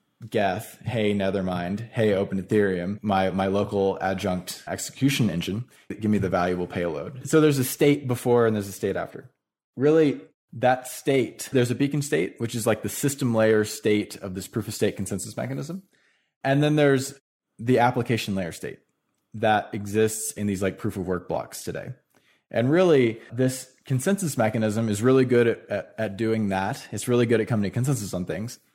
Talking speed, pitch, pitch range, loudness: 180 wpm, 110 Hz, 100-130 Hz, -24 LUFS